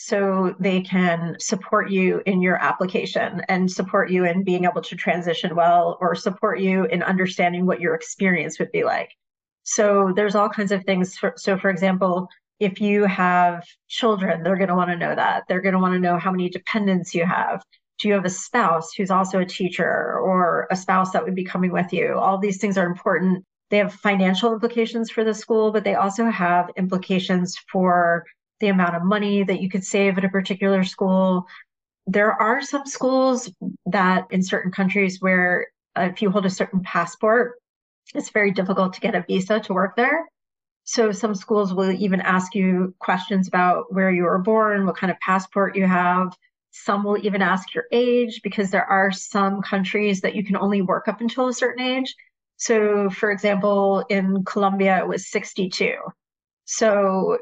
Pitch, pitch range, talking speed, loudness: 195 Hz, 185-210 Hz, 190 wpm, -21 LUFS